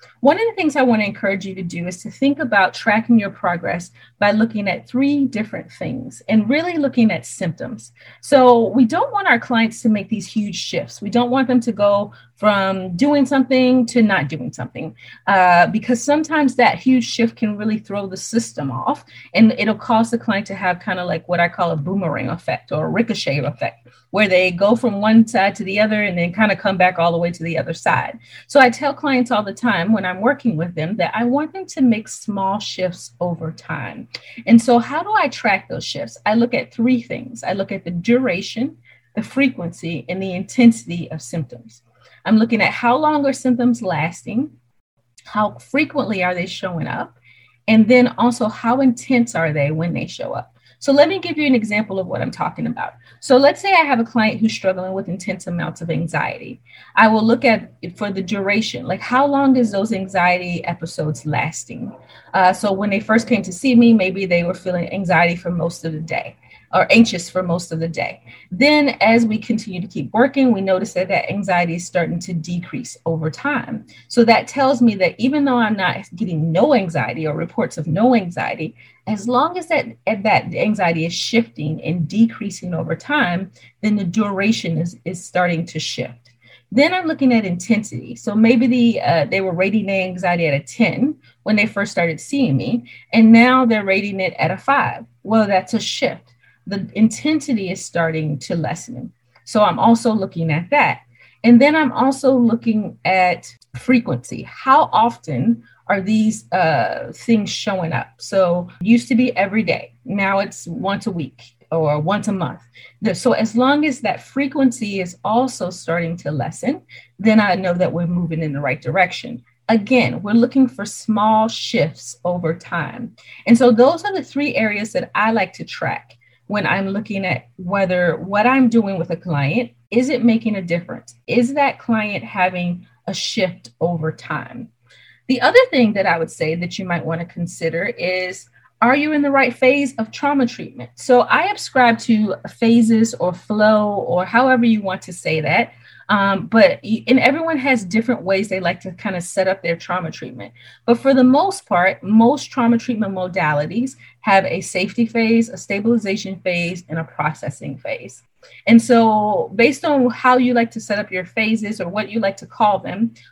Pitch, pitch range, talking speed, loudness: 205 Hz, 175-240 Hz, 200 wpm, -18 LUFS